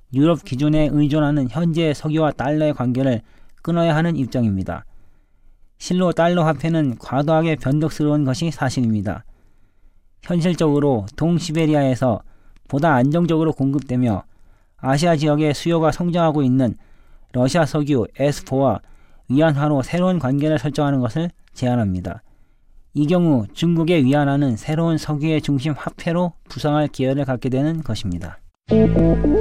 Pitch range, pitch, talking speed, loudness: 120-160 Hz, 145 Hz, 315 characters per minute, -19 LUFS